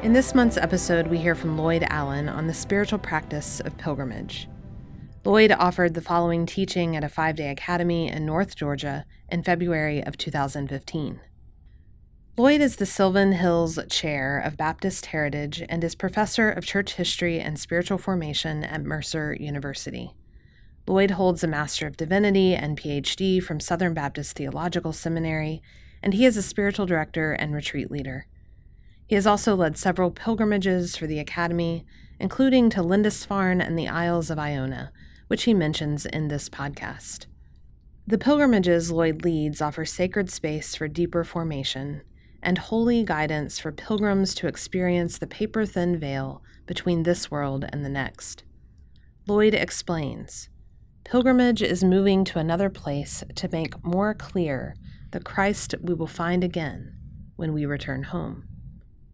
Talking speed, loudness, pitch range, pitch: 150 wpm, -25 LUFS, 150-190 Hz, 170 Hz